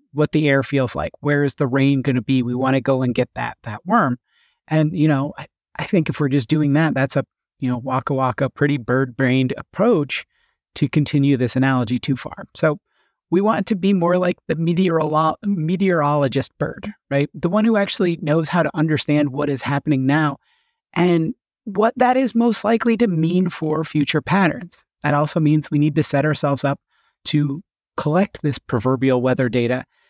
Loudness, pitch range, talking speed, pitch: -19 LUFS, 135-175 Hz, 195 wpm, 150 Hz